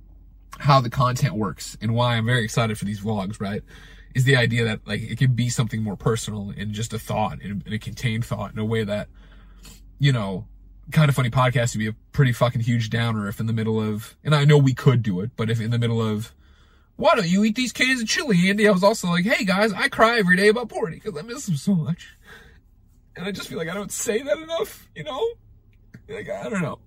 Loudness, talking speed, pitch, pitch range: -22 LUFS, 245 wpm, 120 Hz, 110-175 Hz